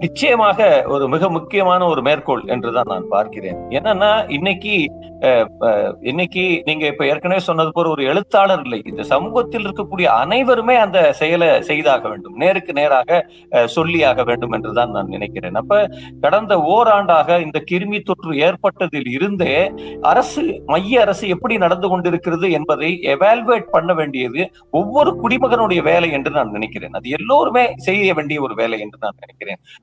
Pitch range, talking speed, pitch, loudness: 150-205 Hz, 135 wpm, 175 Hz, -16 LUFS